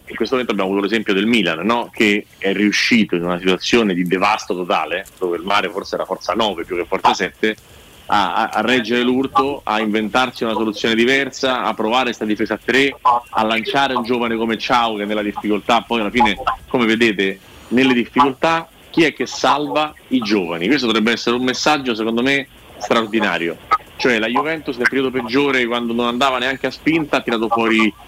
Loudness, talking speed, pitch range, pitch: -17 LUFS, 190 wpm, 105-130 Hz, 120 Hz